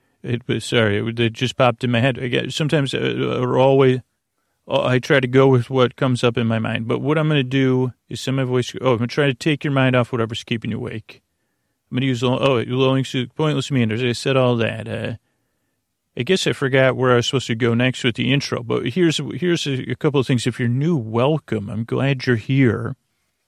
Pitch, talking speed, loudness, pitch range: 130 Hz, 240 wpm, -19 LUFS, 120-135 Hz